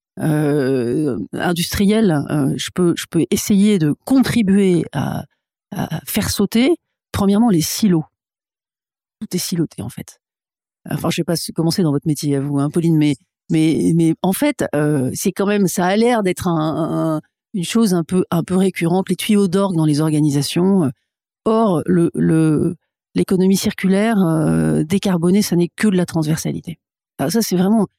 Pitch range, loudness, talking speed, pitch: 155-200 Hz, -17 LUFS, 170 wpm, 175 Hz